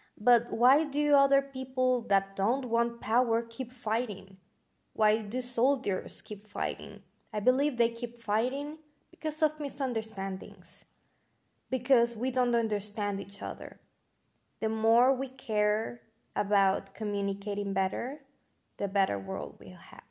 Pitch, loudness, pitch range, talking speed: 230 Hz, -30 LUFS, 205-260 Hz, 125 wpm